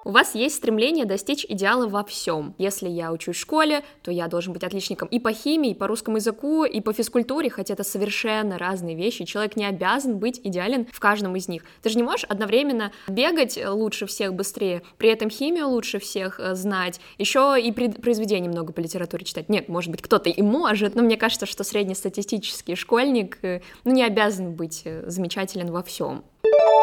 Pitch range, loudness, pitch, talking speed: 185-235 Hz, -24 LUFS, 205 Hz, 185 wpm